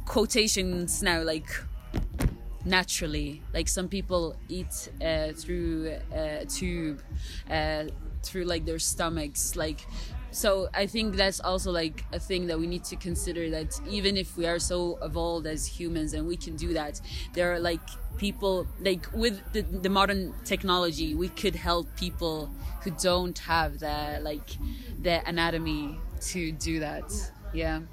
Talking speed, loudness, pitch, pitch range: 150 wpm, -30 LUFS, 170 Hz, 155-185 Hz